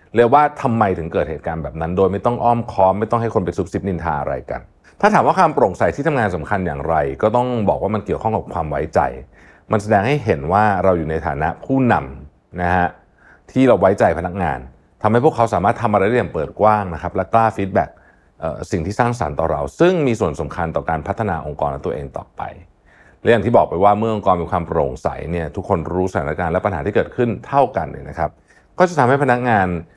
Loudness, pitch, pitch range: -18 LUFS, 100 Hz, 85-115 Hz